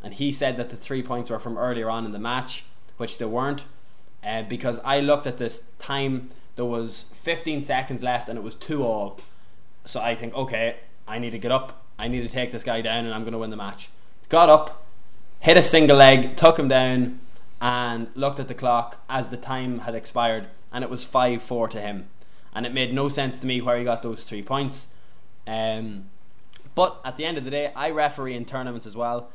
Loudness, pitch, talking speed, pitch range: -22 LUFS, 120 Hz, 225 wpm, 115-135 Hz